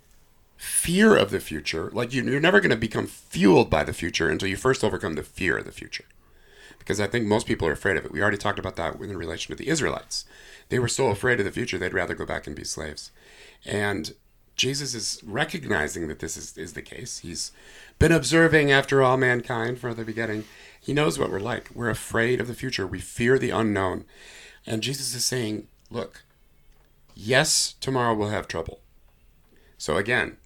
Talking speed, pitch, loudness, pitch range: 200 wpm, 115 Hz, -24 LUFS, 105-130 Hz